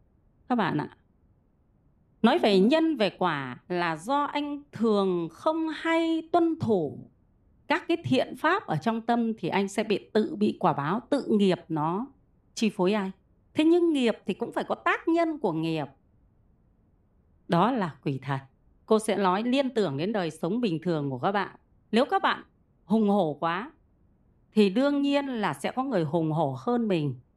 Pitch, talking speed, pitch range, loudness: 205 Hz, 180 wpm, 165-280 Hz, -27 LUFS